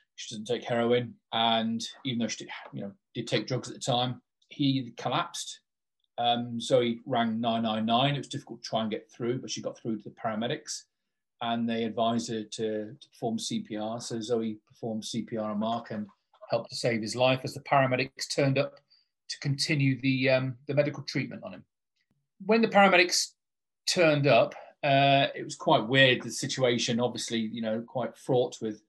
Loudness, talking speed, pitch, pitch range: -28 LUFS, 185 wpm, 120 Hz, 115-140 Hz